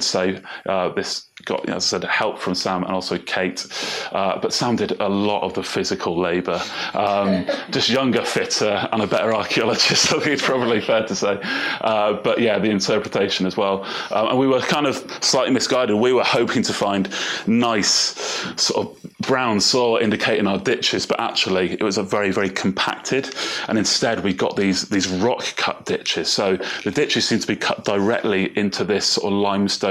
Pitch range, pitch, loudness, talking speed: 95-100 Hz, 100 Hz, -20 LUFS, 195 wpm